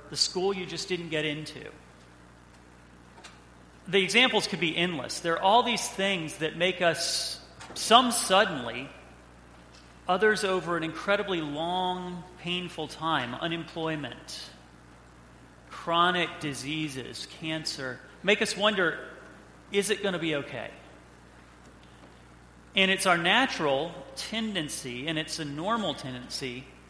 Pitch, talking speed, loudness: 160 Hz, 115 wpm, -27 LUFS